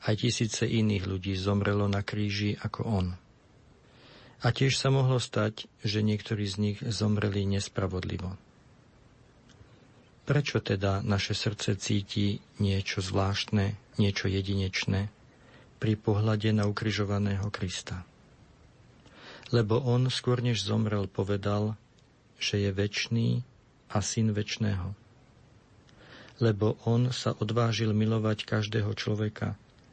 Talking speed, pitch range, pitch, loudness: 105 wpm, 100-120 Hz, 110 Hz, -29 LUFS